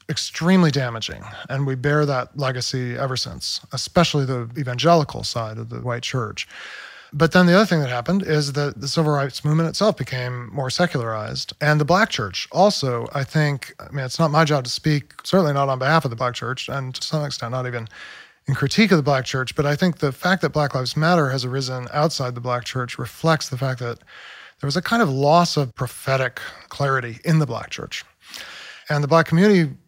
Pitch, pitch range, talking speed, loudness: 140 Hz, 125-160 Hz, 210 wpm, -21 LUFS